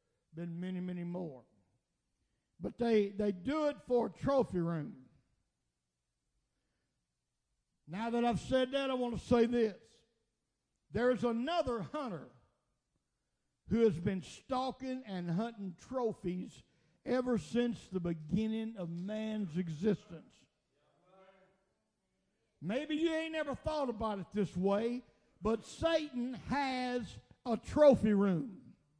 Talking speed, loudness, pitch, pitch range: 115 wpm, -35 LUFS, 220 Hz, 180-250 Hz